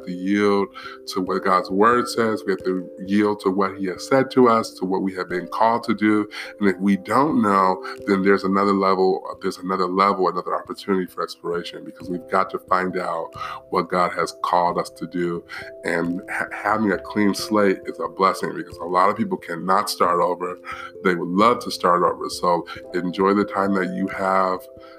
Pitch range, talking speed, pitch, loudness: 90-100 Hz, 205 wpm, 95 Hz, -21 LUFS